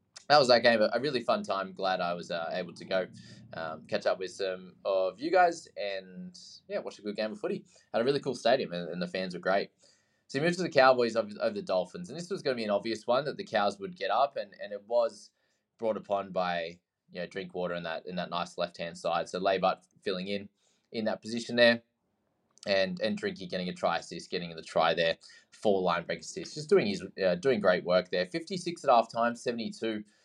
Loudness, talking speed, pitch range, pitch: -30 LUFS, 245 wpm, 95-130 Hz, 110 Hz